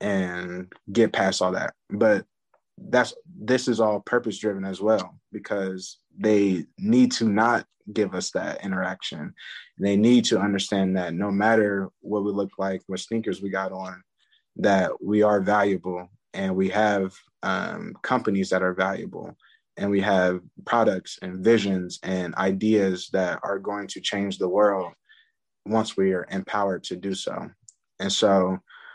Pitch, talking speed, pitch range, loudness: 100 Hz, 155 wpm, 95-105 Hz, -24 LUFS